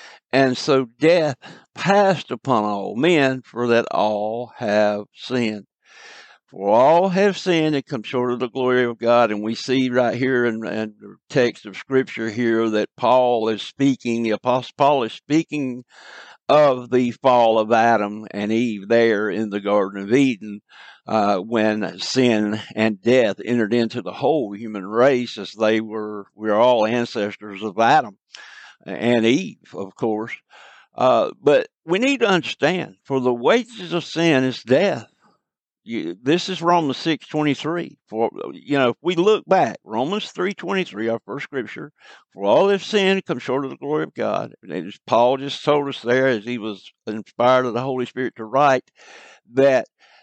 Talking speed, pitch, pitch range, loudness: 170 wpm, 125 Hz, 110-140 Hz, -20 LUFS